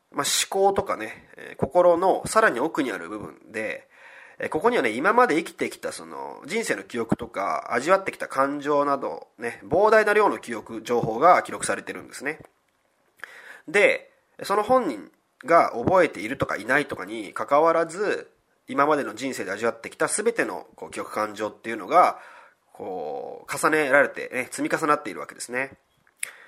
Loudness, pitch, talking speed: -23 LUFS, 220 Hz, 325 characters per minute